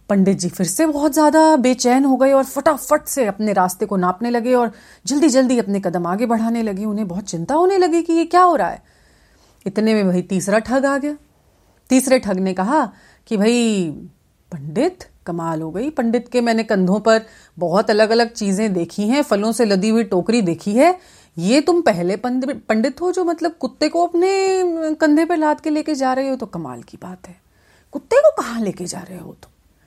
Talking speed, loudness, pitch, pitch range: 205 wpm, -17 LUFS, 230 Hz, 195-300 Hz